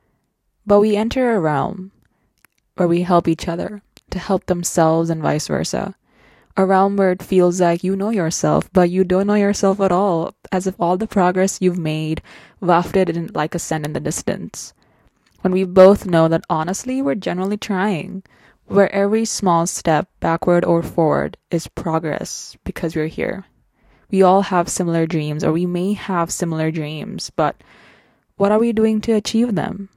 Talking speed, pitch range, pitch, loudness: 175 wpm, 165-200 Hz, 185 Hz, -18 LUFS